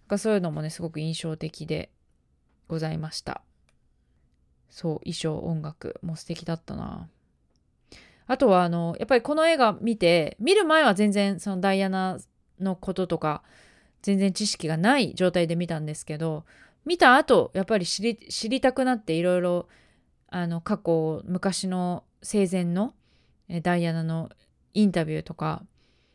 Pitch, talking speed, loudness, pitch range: 175 Hz, 285 characters per minute, -25 LUFS, 160-200 Hz